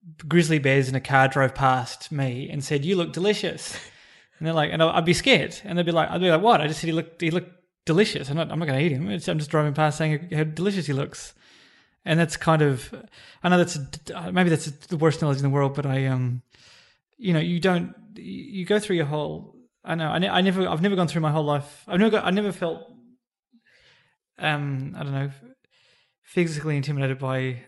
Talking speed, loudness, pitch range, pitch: 240 wpm, -24 LUFS, 145-180 Hz, 160 Hz